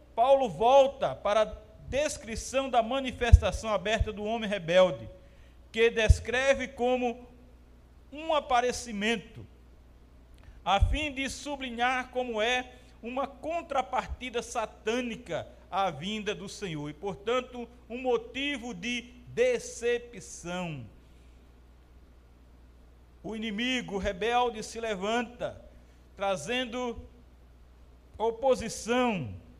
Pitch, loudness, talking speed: 225 Hz, -29 LUFS, 85 wpm